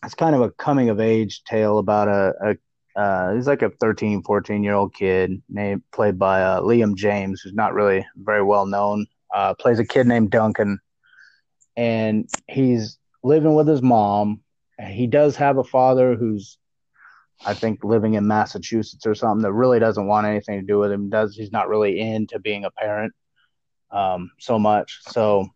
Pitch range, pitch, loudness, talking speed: 100-115 Hz, 105 Hz, -20 LUFS, 185 wpm